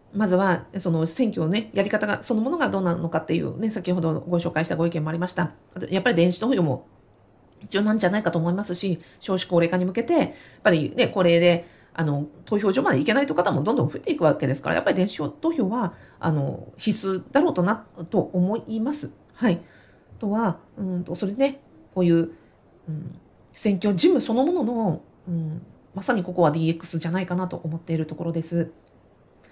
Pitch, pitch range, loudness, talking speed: 180 Hz, 165-210 Hz, -24 LUFS, 370 characters per minute